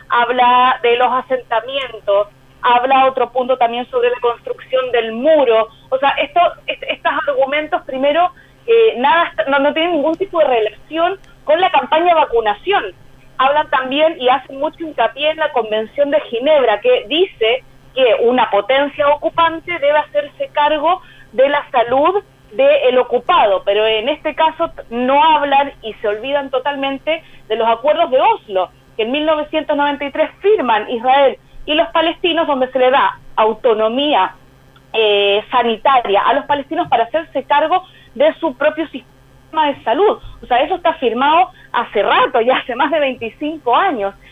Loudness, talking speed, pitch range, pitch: -15 LUFS, 155 wpm, 245-320 Hz, 285 Hz